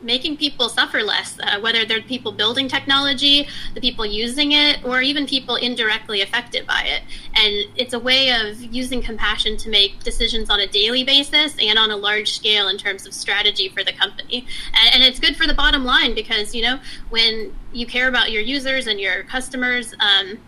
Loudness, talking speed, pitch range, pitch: -17 LUFS, 195 wpm, 215-260 Hz, 235 Hz